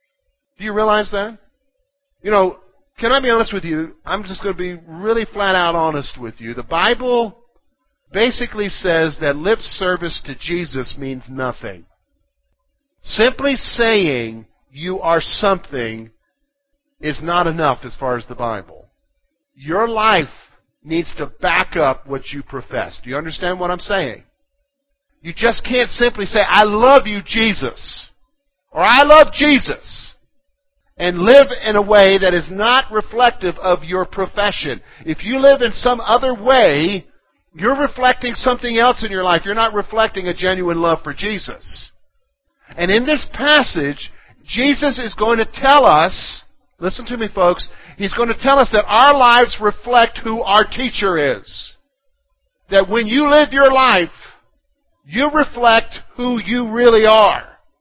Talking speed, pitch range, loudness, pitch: 155 wpm, 170-250 Hz, -15 LUFS, 210 Hz